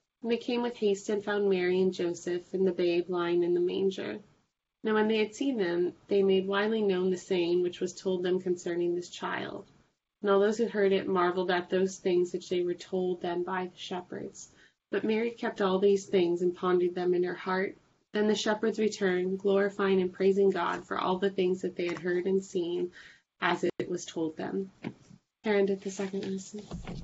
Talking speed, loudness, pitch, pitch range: 205 wpm, -30 LUFS, 185 Hz, 180-200 Hz